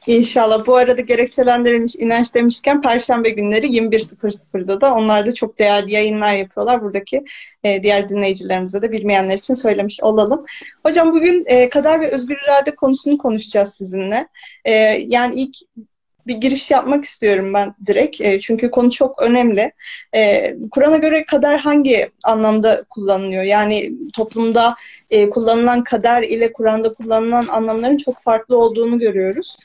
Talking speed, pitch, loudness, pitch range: 130 wpm, 235 Hz, -15 LUFS, 210-265 Hz